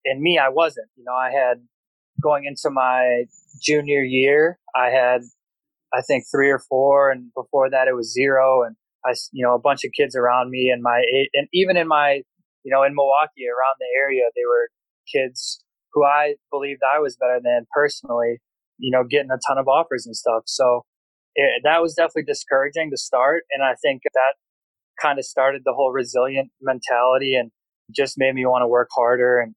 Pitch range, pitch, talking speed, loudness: 125-145 Hz, 135 Hz, 200 wpm, -20 LUFS